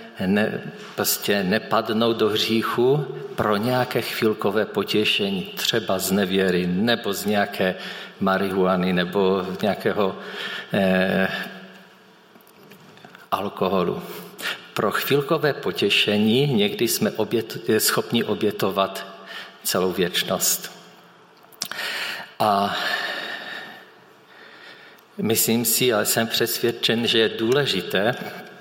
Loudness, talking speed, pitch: -22 LUFS, 85 wpm, 115 Hz